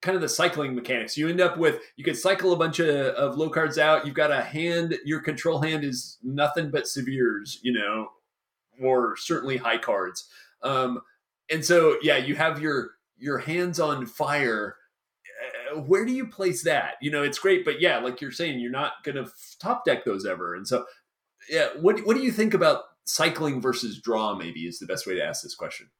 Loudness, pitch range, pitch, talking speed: -25 LUFS, 130-175 Hz, 155 Hz, 210 wpm